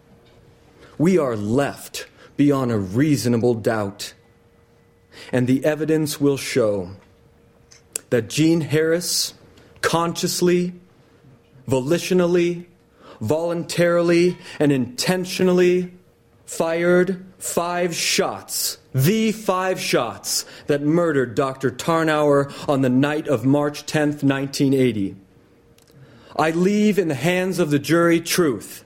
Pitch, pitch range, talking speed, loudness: 150 Hz, 125-175 Hz, 95 wpm, -20 LUFS